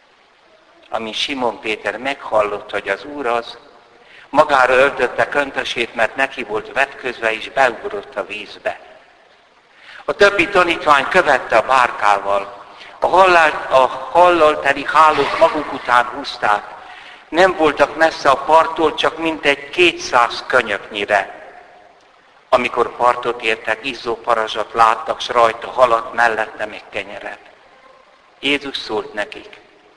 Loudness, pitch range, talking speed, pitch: -16 LUFS, 115-155 Hz, 115 wpm, 130 Hz